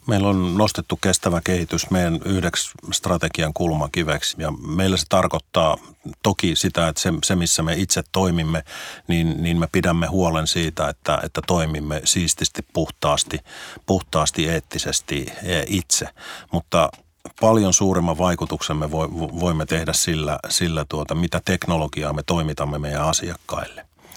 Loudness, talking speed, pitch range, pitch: -21 LUFS, 130 wpm, 80-90 Hz, 85 Hz